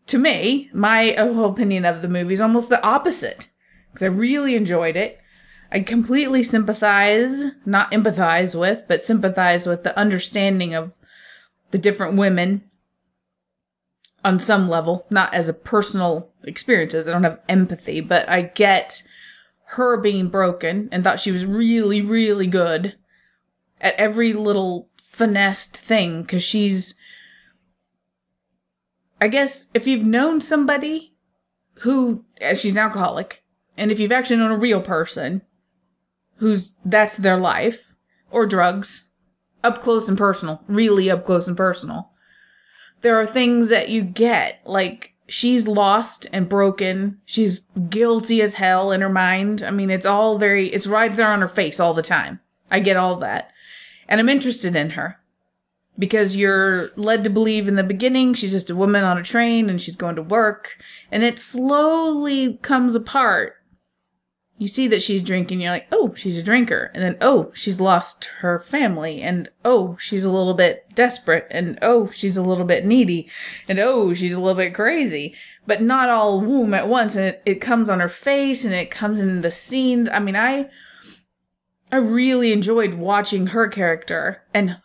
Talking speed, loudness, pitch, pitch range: 165 wpm, -19 LUFS, 205 Hz, 185-230 Hz